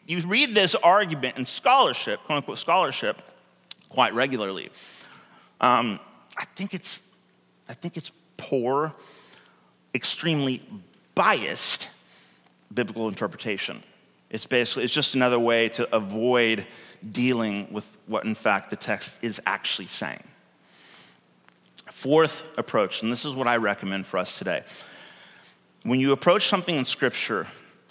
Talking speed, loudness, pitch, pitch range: 125 wpm, -25 LUFS, 125 Hz, 110-160 Hz